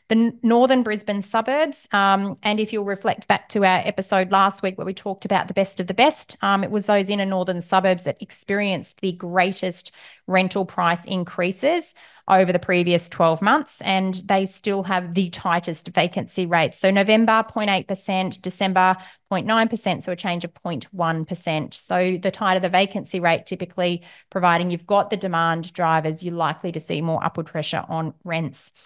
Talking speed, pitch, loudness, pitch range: 175 wpm, 190 Hz, -21 LUFS, 175-200 Hz